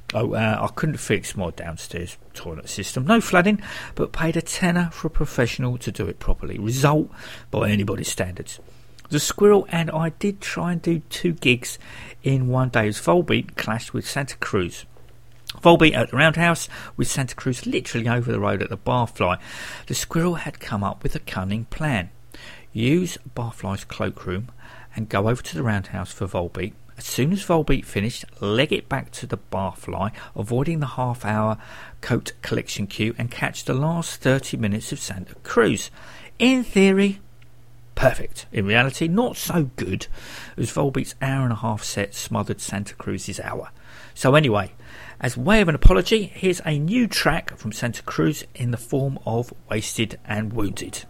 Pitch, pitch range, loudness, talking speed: 125 Hz, 110-160 Hz, -23 LUFS, 170 wpm